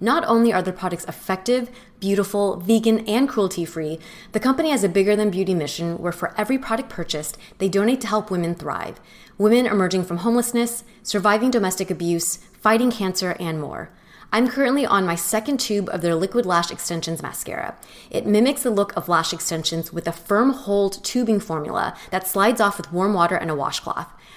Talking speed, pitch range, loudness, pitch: 185 wpm, 175-225 Hz, -21 LUFS, 200 Hz